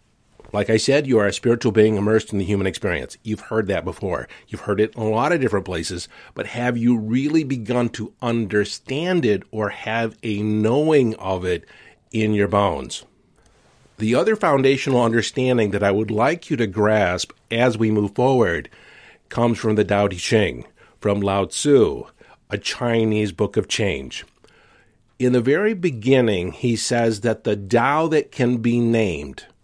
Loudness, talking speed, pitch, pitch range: -20 LUFS, 170 wpm, 110 Hz, 105-125 Hz